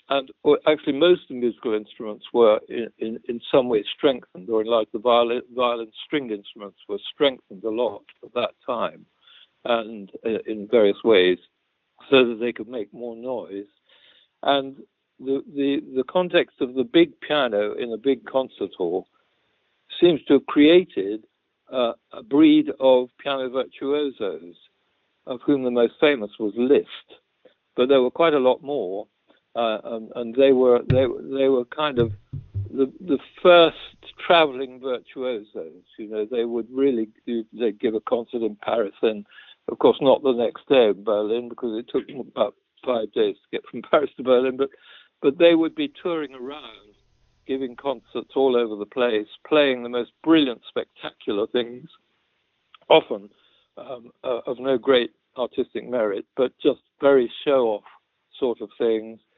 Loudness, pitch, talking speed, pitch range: -22 LUFS, 130 Hz, 165 wpm, 115-145 Hz